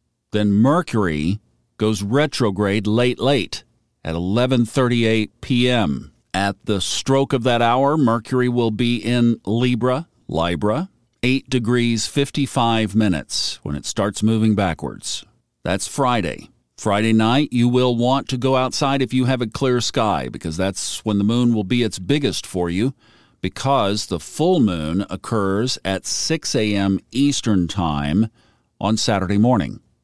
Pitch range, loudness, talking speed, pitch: 100-125 Hz, -20 LUFS, 140 wpm, 110 Hz